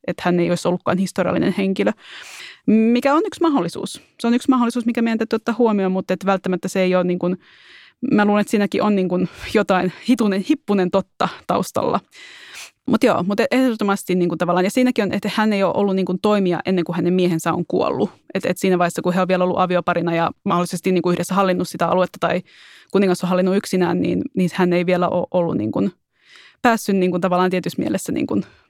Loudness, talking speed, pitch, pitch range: -19 LUFS, 215 wpm, 185 Hz, 180-210 Hz